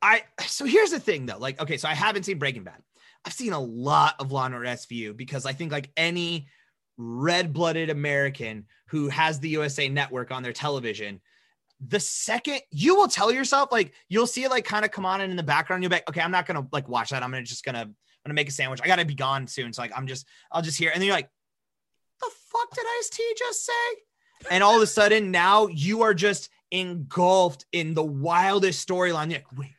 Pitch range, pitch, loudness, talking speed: 135-205 Hz, 160 Hz, -25 LUFS, 235 wpm